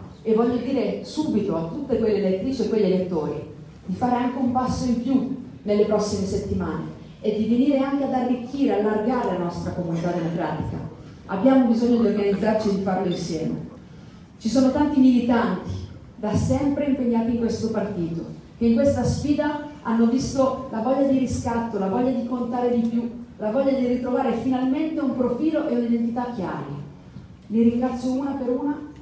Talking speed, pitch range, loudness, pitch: 170 wpm, 210-260 Hz, -23 LUFS, 240 Hz